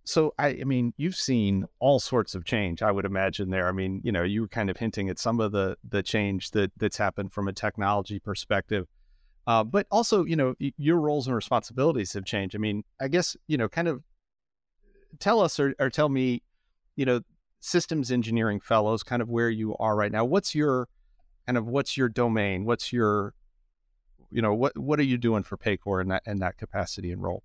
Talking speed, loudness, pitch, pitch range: 215 wpm, -27 LUFS, 110 Hz, 100-135 Hz